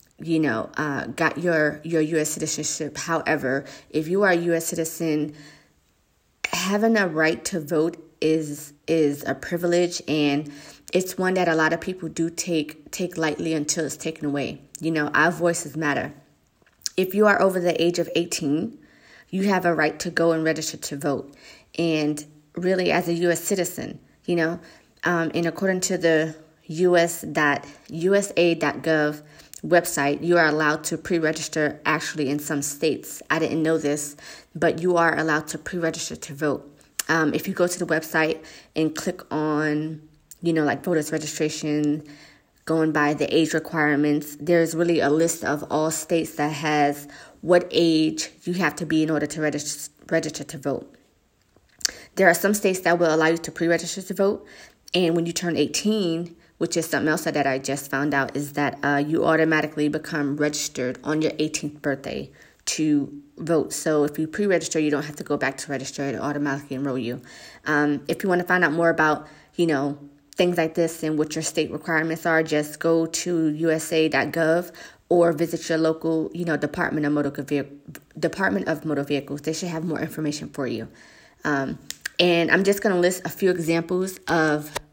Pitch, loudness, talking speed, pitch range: 160 Hz, -23 LUFS, 180 wpm, 150-170 Hz